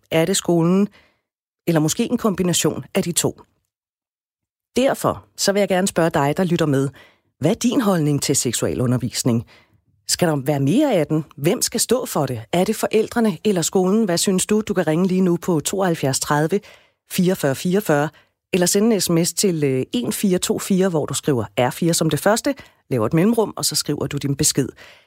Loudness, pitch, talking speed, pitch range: -19 LUFS, 170 Hz, 185 wpm, 145-200 Hz